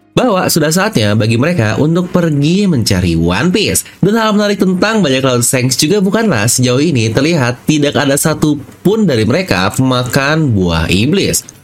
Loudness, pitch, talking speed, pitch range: -11 LUFS, 140 Hz, 155 wpm, 115-180 Hz